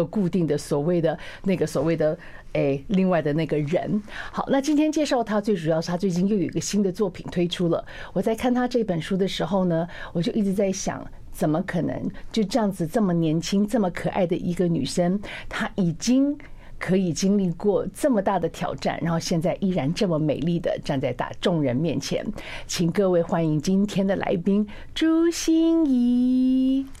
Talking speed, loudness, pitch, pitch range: 280 characters per minute, -24 LUFS, 190 Hz, 170-215 Hz